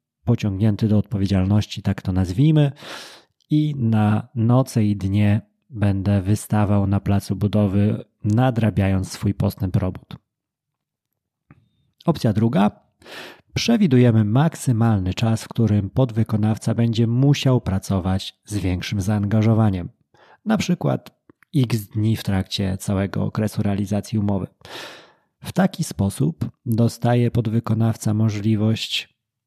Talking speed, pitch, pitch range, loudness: 100 wpm, 110 Hz, 100-120 Hz, -21 LUFS